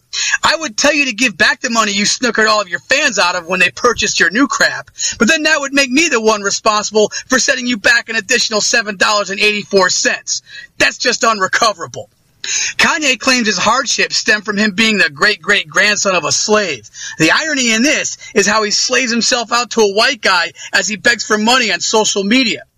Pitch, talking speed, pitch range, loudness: 225 Hz, 215 wpm, 210-255 Hz, -12 LUFS